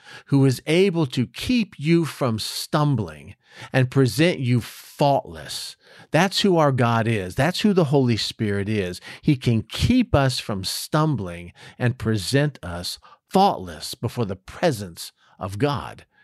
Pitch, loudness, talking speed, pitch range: 130 Hz, -22 LUFS, 140 wpm, 110-150 Hz